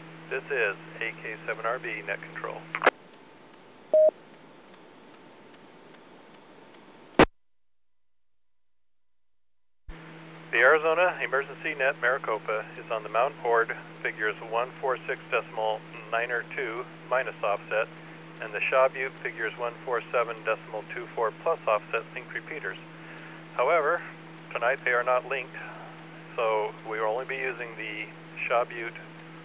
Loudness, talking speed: -28 LUFS, 100 wpm